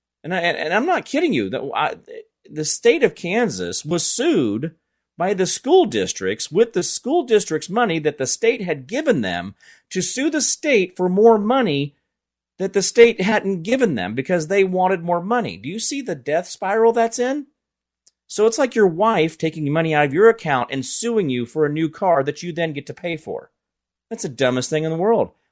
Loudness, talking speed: -19 LUFS, 205 wpm